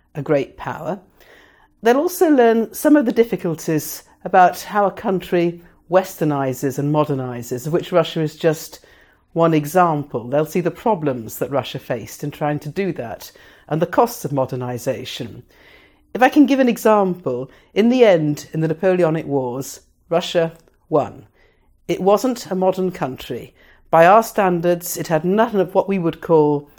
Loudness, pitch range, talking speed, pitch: -18 LUFS, 150-195 Hz, 160 wpm, 170 Hz